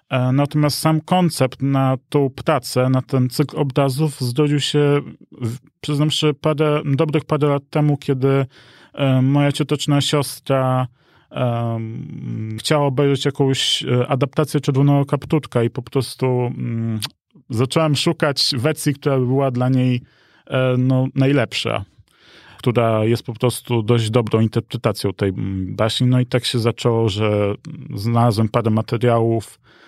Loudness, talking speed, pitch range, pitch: -19 LUFS, 125 wpm, 120-145 Hz, 130 Hz